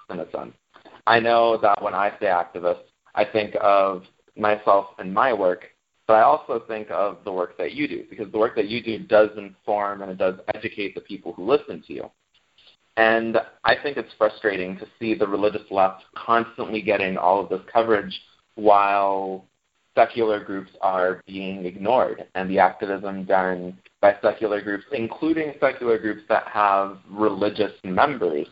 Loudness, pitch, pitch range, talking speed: -22 LUFS, 105 Hz, 95-115 Hz, 165 wpm